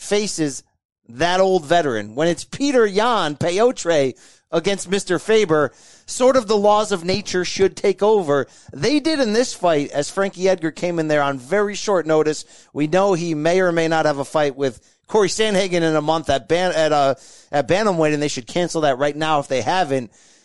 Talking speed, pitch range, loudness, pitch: 200 wpm, 150-200 Hz, -19 LUFS, 170 Hz